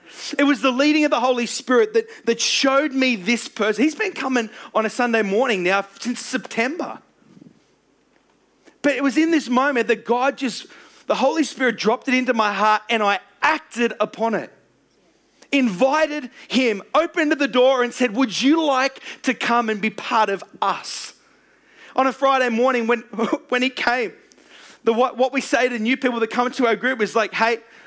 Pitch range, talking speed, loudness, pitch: 230-270 Hz, 185 wpm, -20 LUFS, 250 Hz